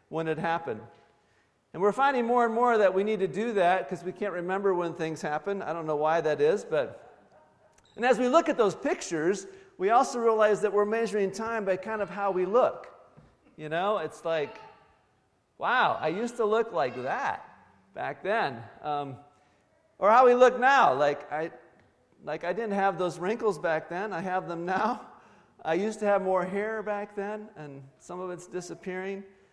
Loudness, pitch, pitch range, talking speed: -27 LUFS, 195 Hz, 170-220 Hz, 195 wpm